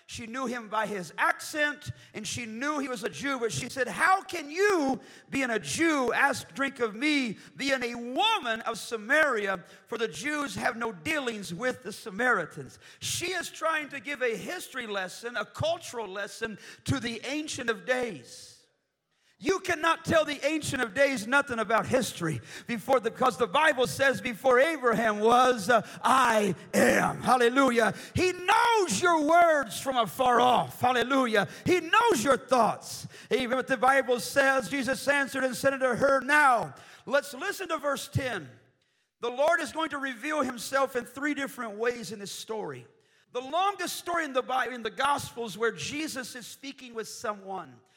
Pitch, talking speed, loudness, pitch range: 255 Hz, 170 wpm, -27 LUFS, 230-290 Hz